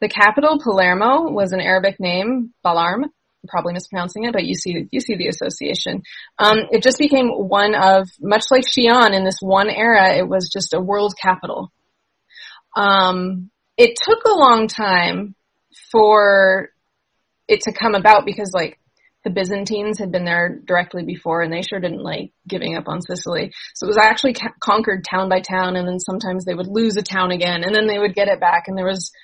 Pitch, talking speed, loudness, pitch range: 200 Hz, 190 wpm, -17 LUFS, 185-220 Hz